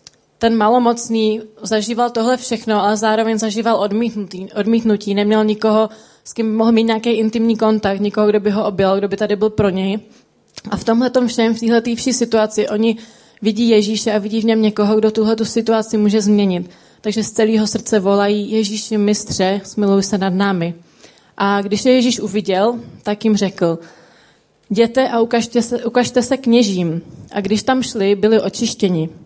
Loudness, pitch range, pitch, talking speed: -16 LUFS, 205-230 Hz, 215 Hz, 170 wpm